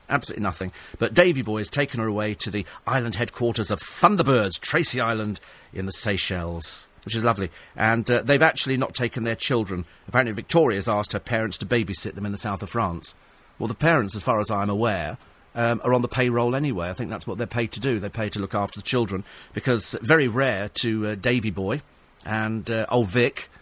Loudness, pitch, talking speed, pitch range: -24 LUFS, 115 Hz, 220 wpm, 100-120 Hz